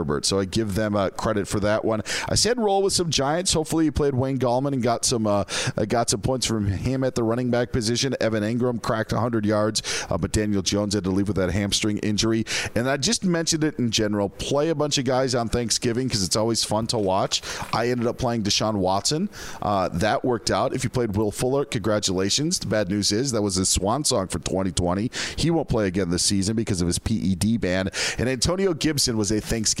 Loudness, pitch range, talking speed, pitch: -23 LUFS, 105-130 Hz, 235 wpm, 115 Hz